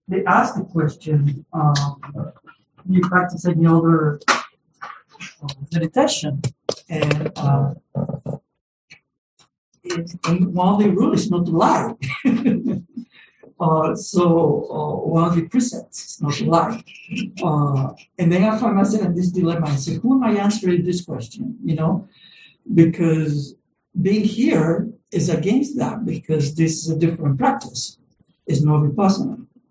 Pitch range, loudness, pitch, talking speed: 155-200 Hz, -20 LUFS, 170 Hz, 140 wpm